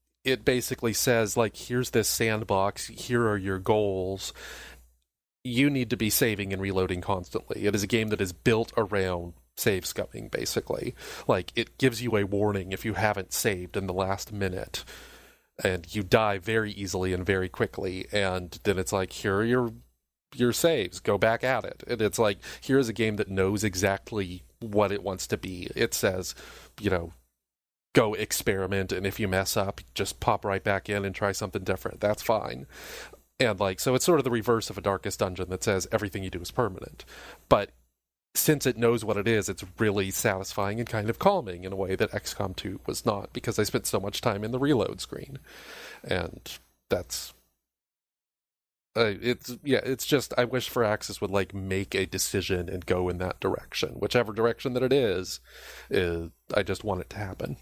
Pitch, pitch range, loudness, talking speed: 100 Hz, 95-115 Hz, -28 LUFS, 195 wpm